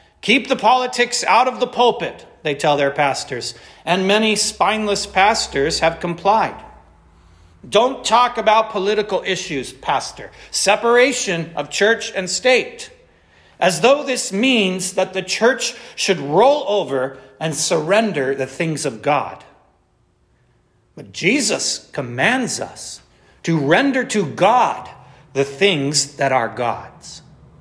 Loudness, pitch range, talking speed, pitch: -17 LUFS, 145-220 Hz, 125 wpm, 185 Hz